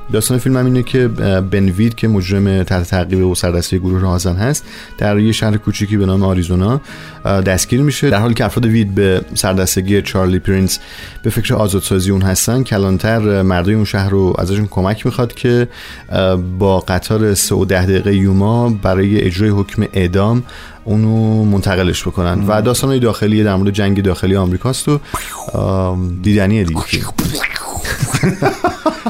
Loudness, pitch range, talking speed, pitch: -14 LUFS, 95-115 Hz, 150 wpm, 100 Hz